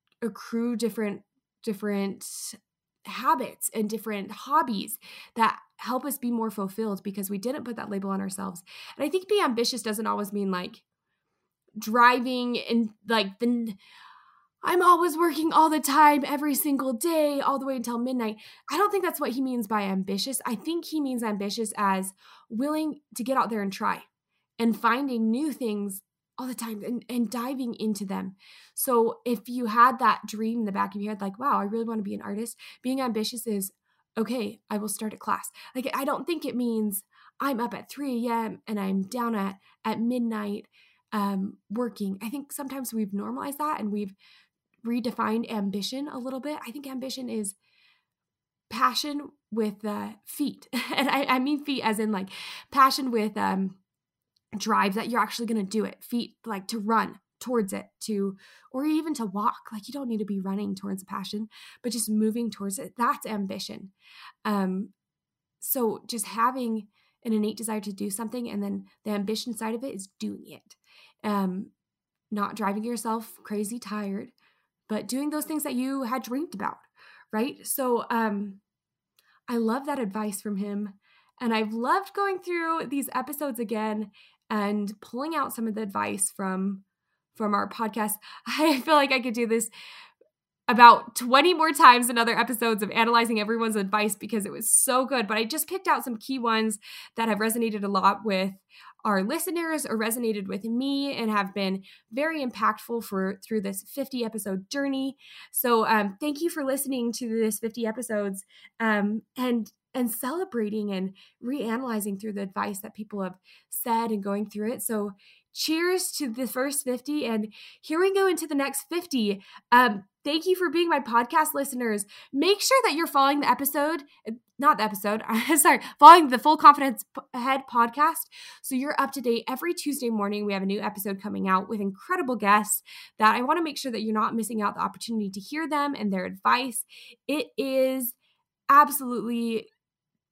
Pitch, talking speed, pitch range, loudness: 230 Hz, 180 wpm, 210-270 Hz, -26 LUFS